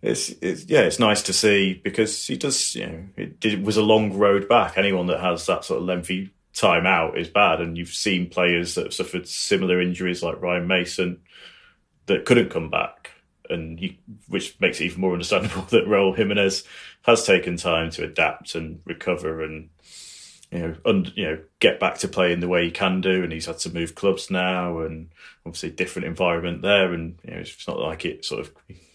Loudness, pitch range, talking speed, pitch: -22 LUFS, 85-95 Hz, 210 wpm, 90 Hz